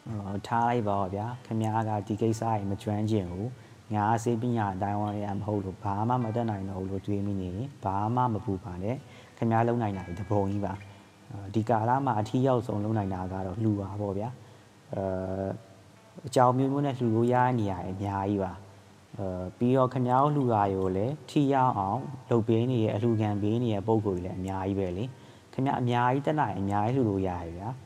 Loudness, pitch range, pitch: -29 LUFS, 100-120 Hz, 105 Hz